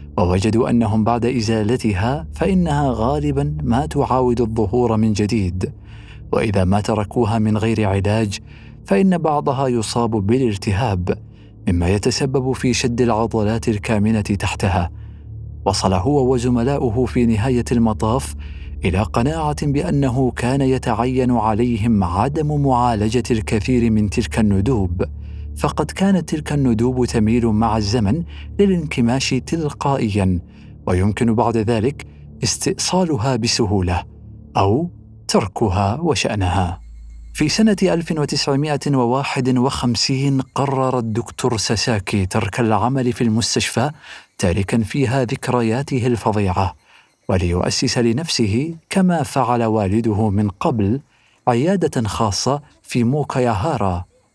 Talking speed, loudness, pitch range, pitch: 95 wpm, -18 LUFS, 105-130 Hz, 115 Hz